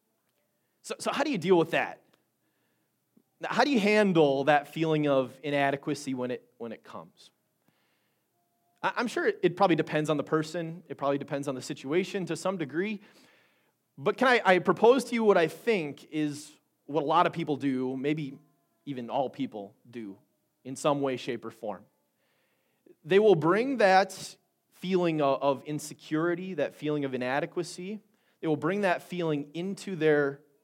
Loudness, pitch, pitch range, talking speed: -28 LUFS, 155 Hz, 140-185 Hz, 170 wpm